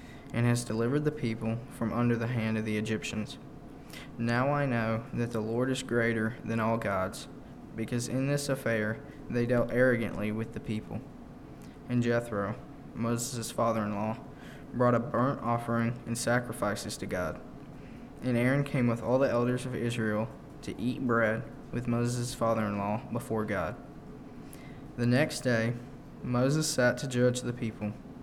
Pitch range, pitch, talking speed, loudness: 110-125 Hz, 120 Hz, 160 wpm, -31 LUFS